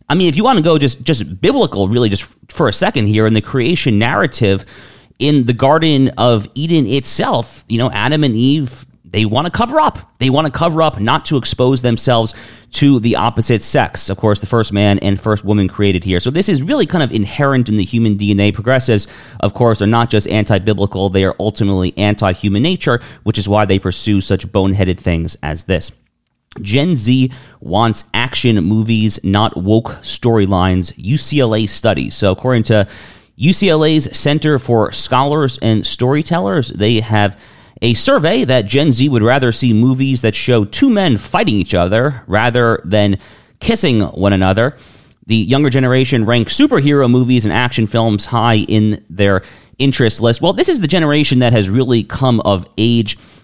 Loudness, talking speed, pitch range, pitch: -13 LUFS, 180 wpm, 105-135 Hz, 115 Hz